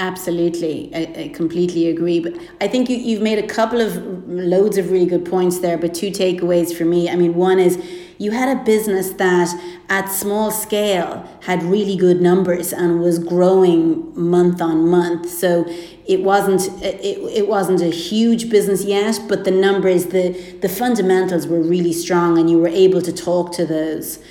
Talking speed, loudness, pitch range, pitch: 185 wpm, -17 LUFS, 175-195 Hz, 180 Hz